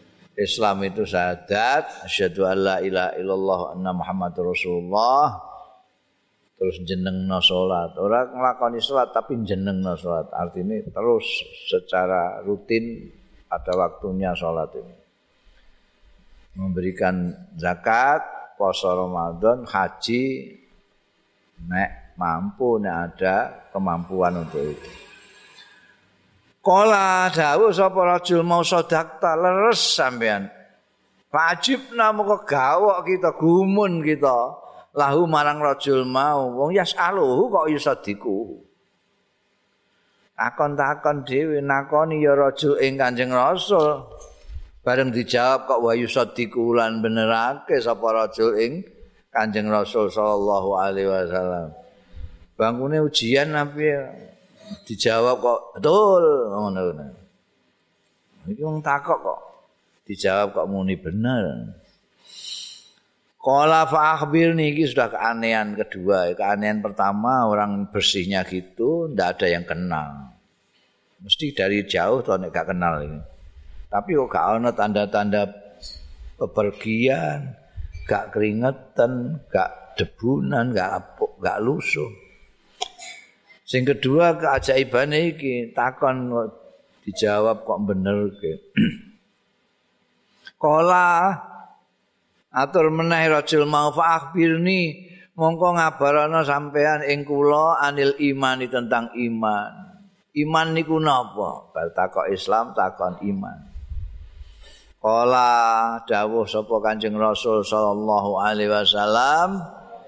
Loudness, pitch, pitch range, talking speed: -21 LUFS, 125 Hz, 100-160 Hz, 95 wpm